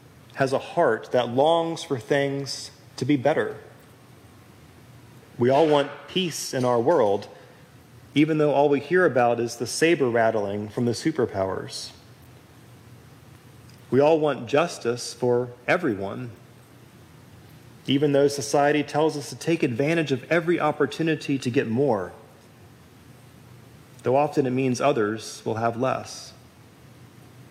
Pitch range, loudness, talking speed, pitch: 120-145 Hz, -23 LUFS, 125 wpm, 130 Hz